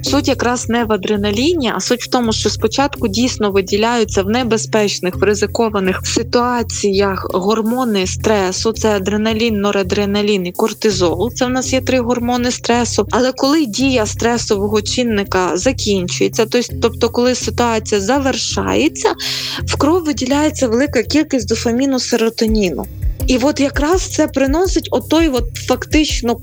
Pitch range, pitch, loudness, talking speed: 210-260 Hz, 235 Hz, -15 LUFS, 130 wpm